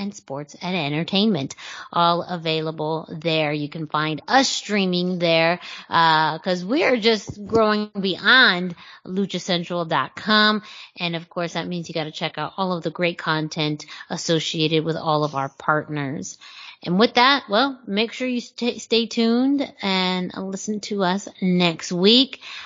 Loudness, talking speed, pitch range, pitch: -21 LUFS, 155 wpm, 160-215 Hz, 180 Hz